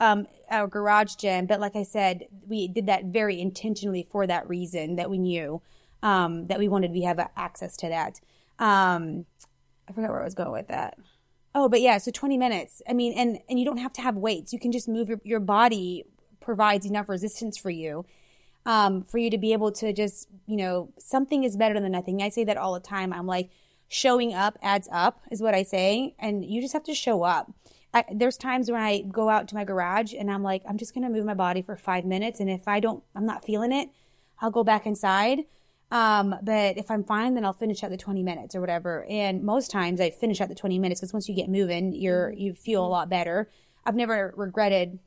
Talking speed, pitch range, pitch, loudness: 230 wpm, 185-225 Hz, 205 Hz, -26 LUFS